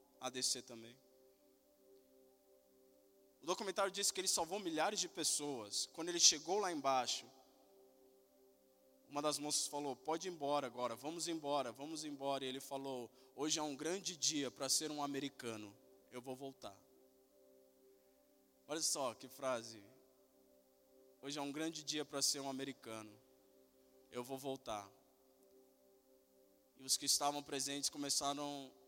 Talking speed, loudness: 135 wpm, -40 LUFS